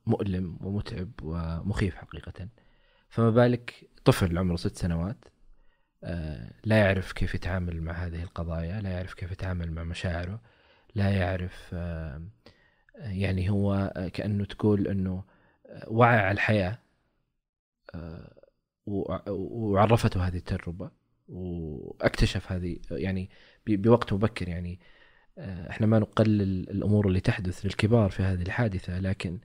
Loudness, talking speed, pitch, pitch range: -28 LUFS, 110 wpm, 95 Hz, 90-105 Hz